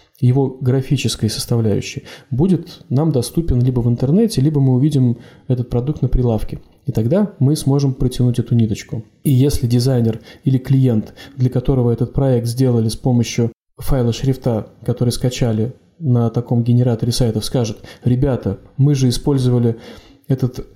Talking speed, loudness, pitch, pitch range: 140 wpm, -17 LUFS, 125 Hz, 120-135 Hz